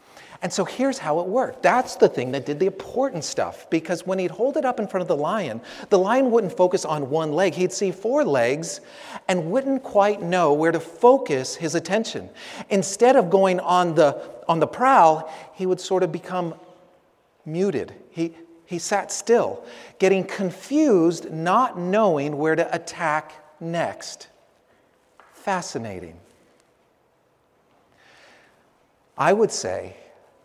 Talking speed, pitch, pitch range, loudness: 150 wpm, 185 Hz, 165-200 Hz, -22 LUFS